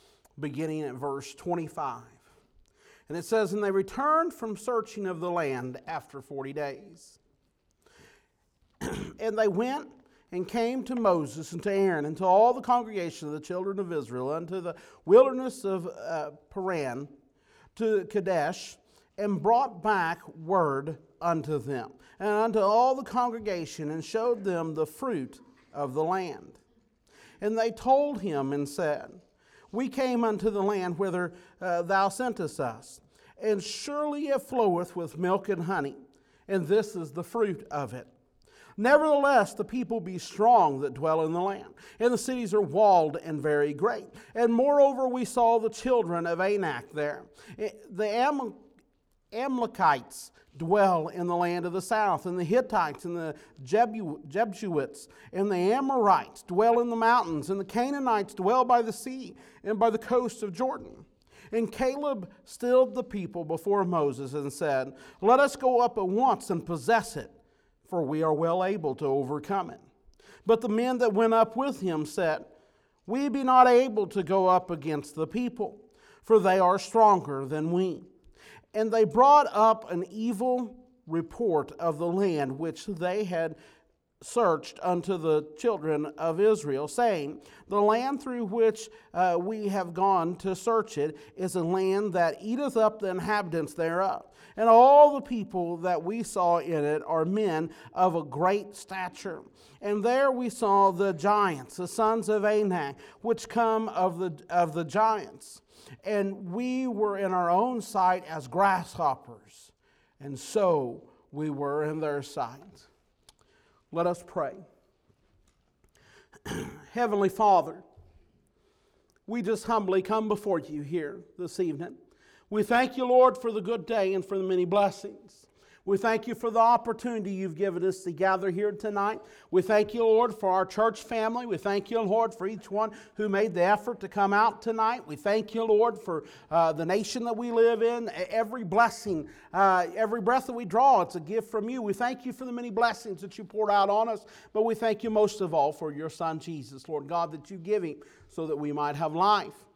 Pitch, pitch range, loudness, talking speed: 200 Hz, 170-230 Hz, -27 LUFS, 170 wpm